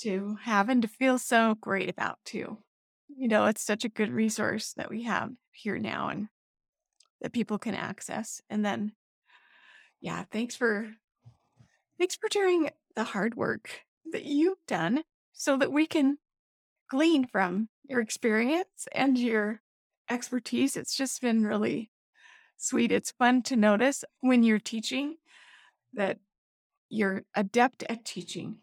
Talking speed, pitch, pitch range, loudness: 145 wpm, 235 Hz, 210-270 Hz, -29 LUFS